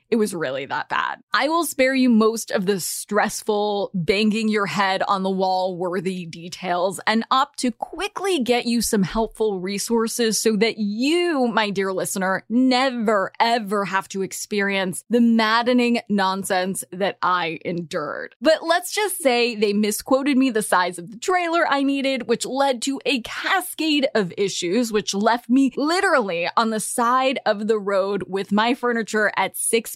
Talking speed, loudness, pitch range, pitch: 165 wpm, -21 LUFS, 195-255 Hz, 220 Hz